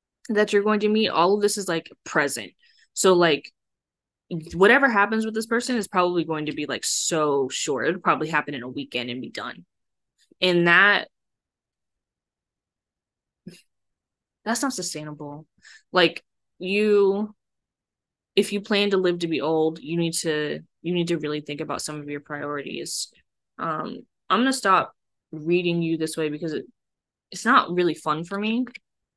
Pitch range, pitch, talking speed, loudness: 150-205 Hz, 170 Hz, 165 wpm, -23 LUFS